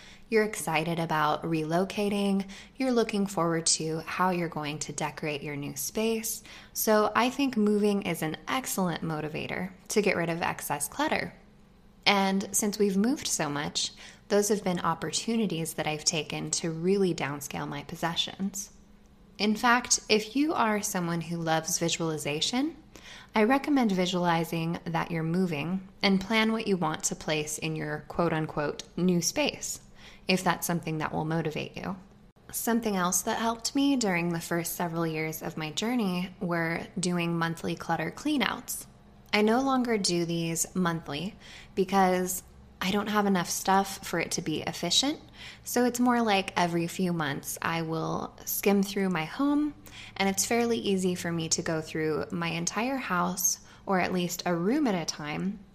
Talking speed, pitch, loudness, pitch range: 165 wpm, 185 Hz, -28 LUFS, 165-210 Hz